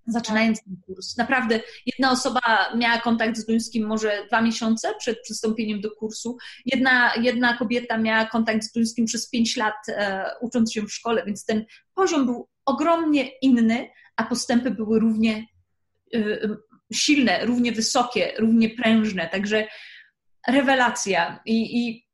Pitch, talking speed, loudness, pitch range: 225 Hz, 140 wpm, -22 LUFS, 220-245 Hz